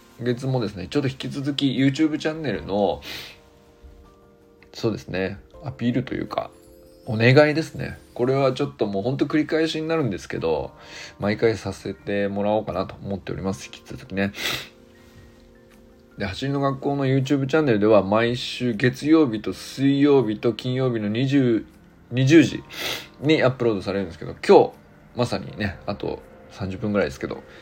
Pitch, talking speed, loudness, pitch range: 120 Hz, 350 characters per minute, -23 LUFS, 100-140 Hz